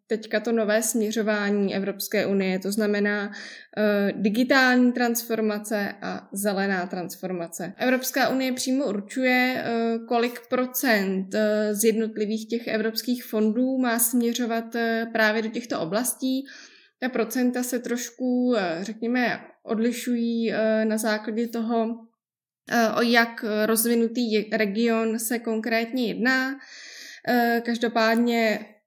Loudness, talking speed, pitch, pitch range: -24 LUFS, 100 wpm, 230 Hz, 215-245 Hz